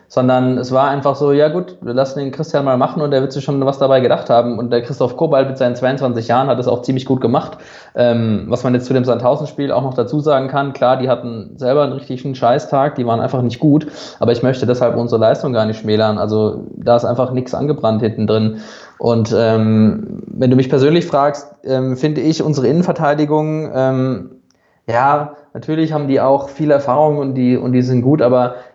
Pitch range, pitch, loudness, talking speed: 120-145 Hz, 130 Hz, -15 LUFS, 220 wpm